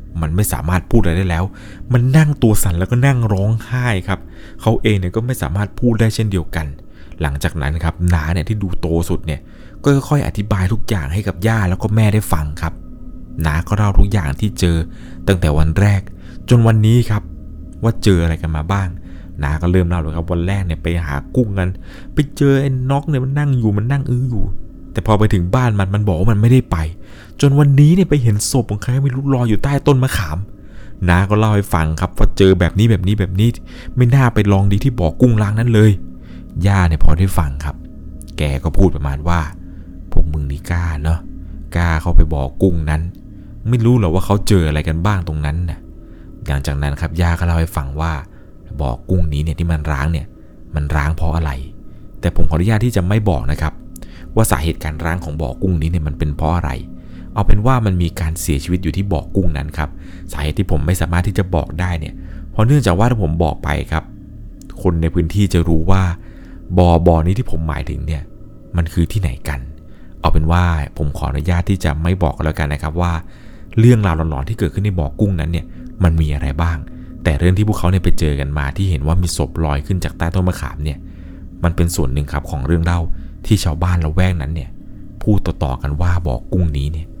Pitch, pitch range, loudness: 90 Hz, 80-105 Hz, -17 LUFS